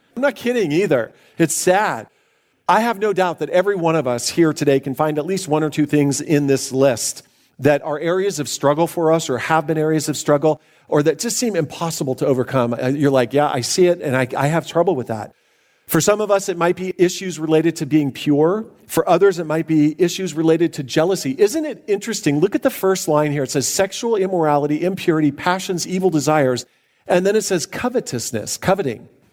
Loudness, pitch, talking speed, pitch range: -18 LUFS, 160 Hz, 215 wpm, 145-185 Hz